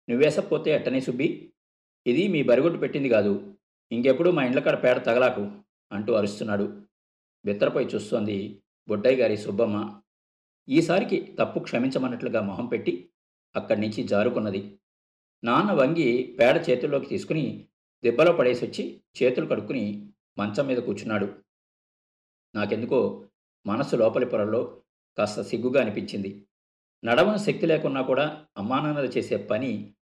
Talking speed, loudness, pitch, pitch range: 110 wpm, -25 LUFS, 105 Hz, 95-125 Hz